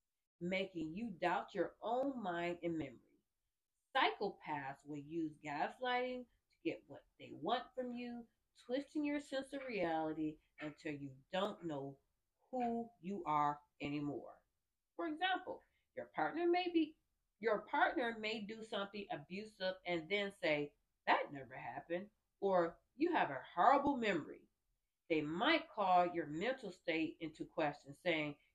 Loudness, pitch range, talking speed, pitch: -40 LUFS, 155-245 Hz, 135 wpm, 185 Hz